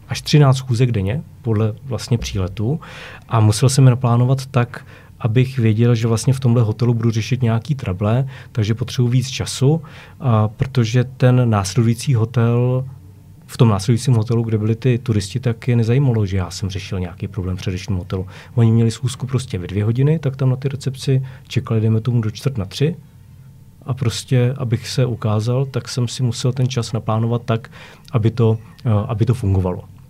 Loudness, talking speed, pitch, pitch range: -18 LUFS, 175 wpm, 120 Hz, 110-130 Hz